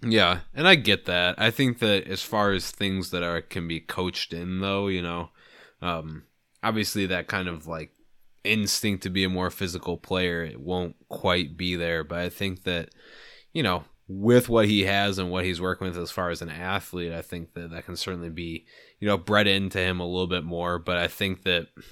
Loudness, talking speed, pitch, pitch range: -26 LUFS, 215 wpm, 90 Hz, 85-100 Hz